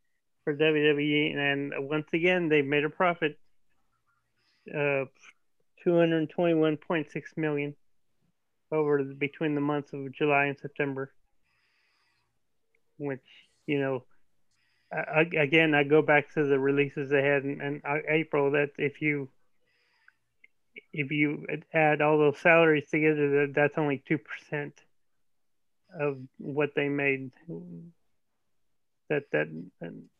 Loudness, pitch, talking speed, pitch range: -27 LUFS, 145 Hz, 120 wpm, 140-155 Hz